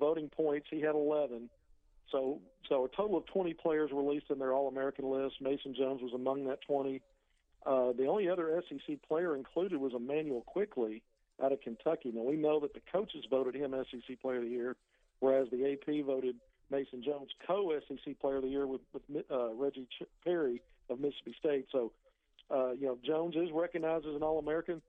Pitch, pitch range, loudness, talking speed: 140 Hz, 130-155 Hz, -36 LUFS, 190 wpm